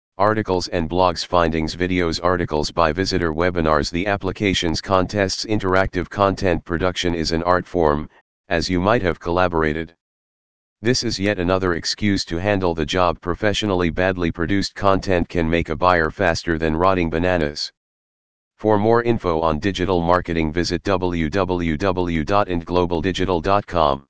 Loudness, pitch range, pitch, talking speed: -20 LUFS, 85-95 Hz, 90 Hz, 130 wpm